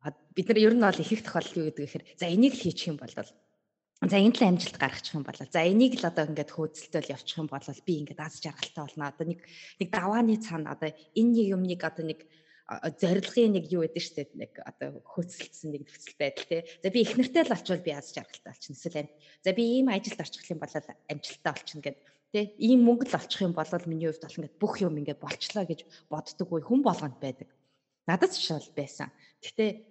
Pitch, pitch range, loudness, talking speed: 165 Hz, 150-200 Hz, -29 LUFS, 220 wpm